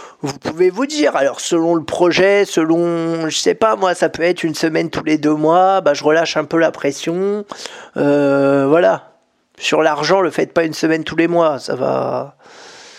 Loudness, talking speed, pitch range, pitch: -15 LUFS, 200 wpm, 155-190 Hz, 165 Hz